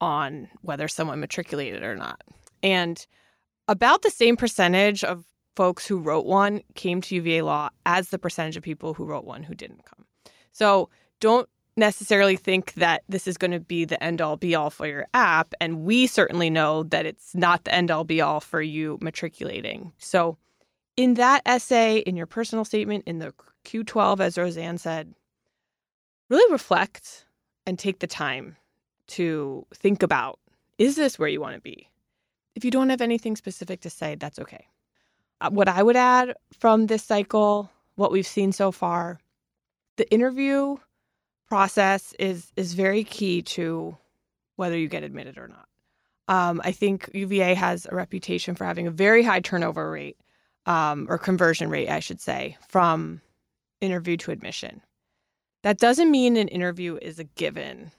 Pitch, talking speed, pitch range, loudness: 185 Hz, 170 wpm, 170-215 Hz, -23 LUFS